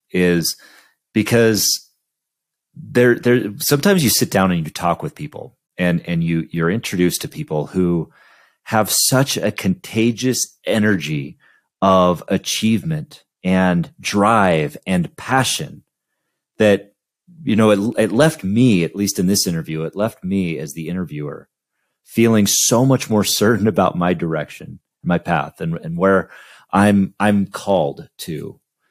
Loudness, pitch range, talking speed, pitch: -17 LUFS, 90-120 Hz, 140 wpm, 100 Hz